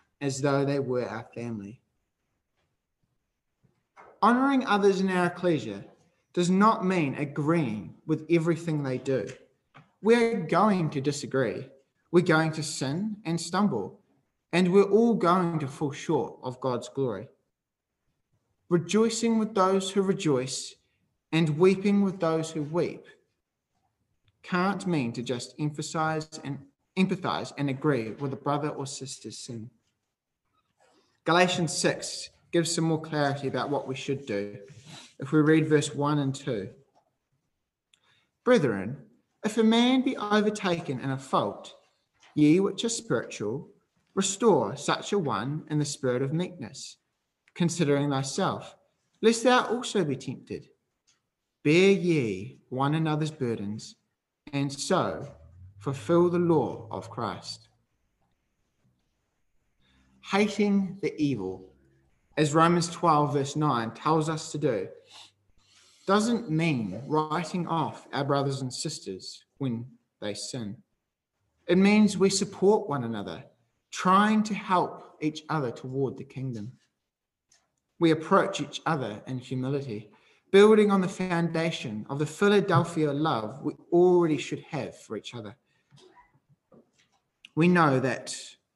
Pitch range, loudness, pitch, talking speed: 130-180 Hz, -27 LUFS, 150 Hz, 125 wpm